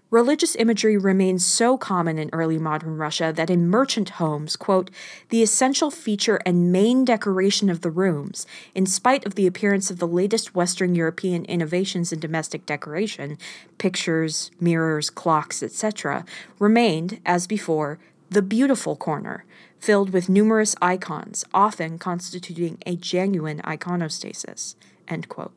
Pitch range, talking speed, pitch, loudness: 165-210 Hz, 135 wpm, 185 Hz, -22 LUFS